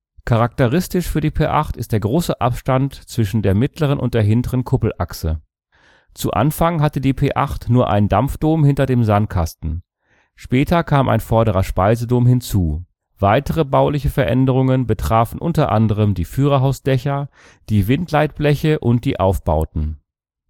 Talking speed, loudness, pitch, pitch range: 130 wpm, -18 LUFS, 125 Hz, 105-140 Hz